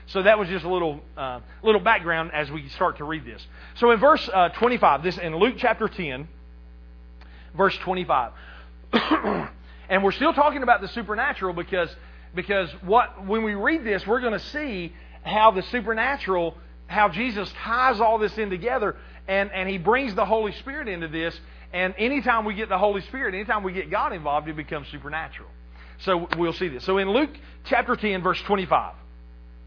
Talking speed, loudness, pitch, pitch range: 180 wpm, -24 LUFS, 190 Hz, 150-220 Hz